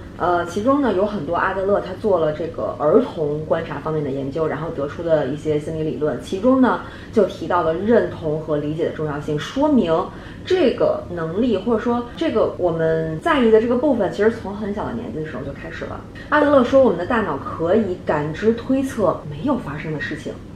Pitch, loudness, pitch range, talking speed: 175 Hz, -20 LUFS, 155-240 Hz, 315 characters per minute